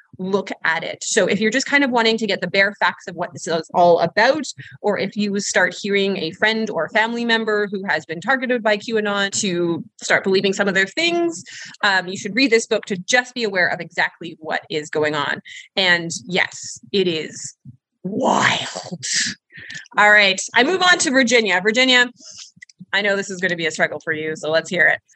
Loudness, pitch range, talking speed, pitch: -18 LUFS, 175-225 Hz, 210 wpm, 200 Hz